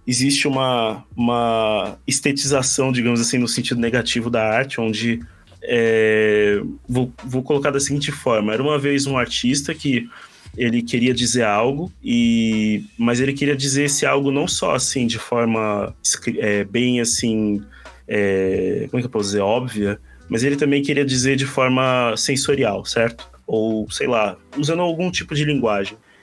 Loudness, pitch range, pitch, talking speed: -19 LUFS, 110-140 Hz, 125 Hz, 160 wpm